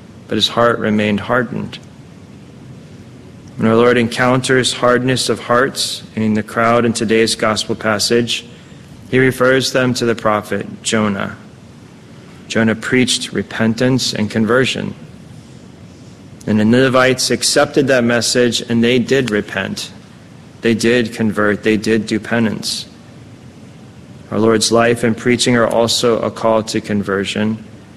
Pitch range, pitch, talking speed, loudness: 110-125 Hz, 115 Hz, 125 wpm, -15 LUFS